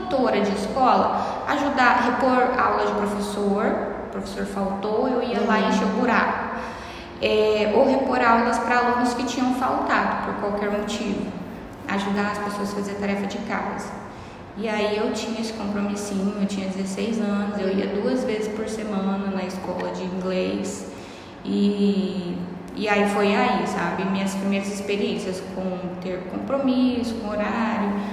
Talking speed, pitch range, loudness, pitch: 155 wpm, 195-225 Hz, -23 LUFS, 205 Hz